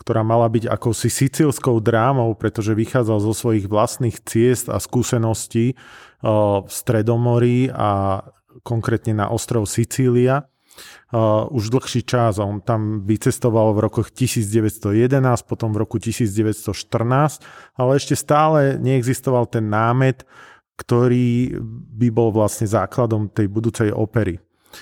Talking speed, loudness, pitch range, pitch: 115 wpm, -19 LUFS, 110-125 Hz, 115 Hz